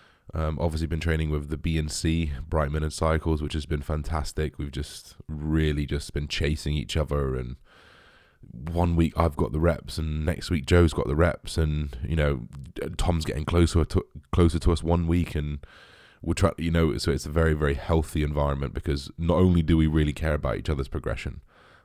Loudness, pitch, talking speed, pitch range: -26 LUFS, 80 Hz, 205 wpm, 75-85 Hz